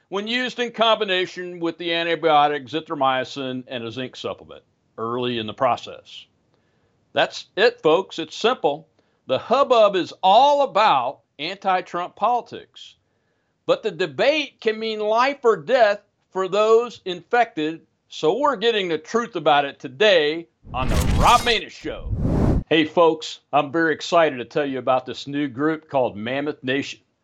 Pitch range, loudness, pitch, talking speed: 145-225 Hz, -21 LUFS, 170 Hz, 150 wpm